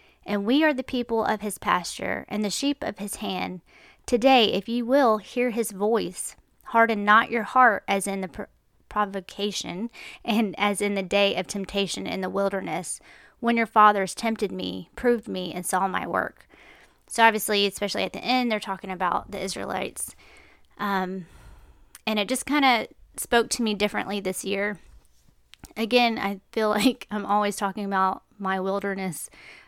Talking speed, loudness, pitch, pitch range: 170 wpm, -25 LUFS, 205 Hz, 195-230 Hz